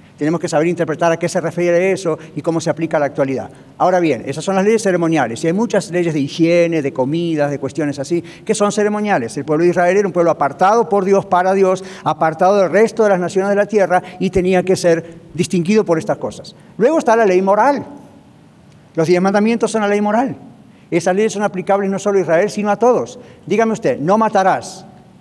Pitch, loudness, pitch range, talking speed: 180 Hz, -16 LUFS, 165-200 Hz, 220 wpm